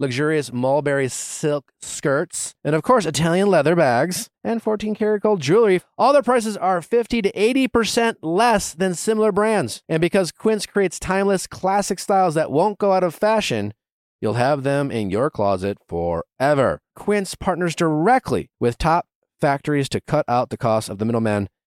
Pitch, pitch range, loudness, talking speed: 175 Hz, 140-210 Hz, -20 LUFS, 165 wpm